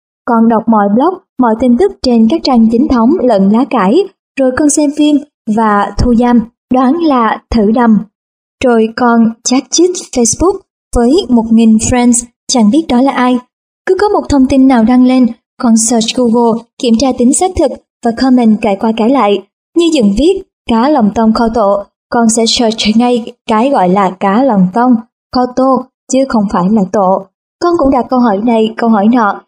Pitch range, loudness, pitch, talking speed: 225-265 Hz, -10 LUFS, 240 Hz, 195 wpm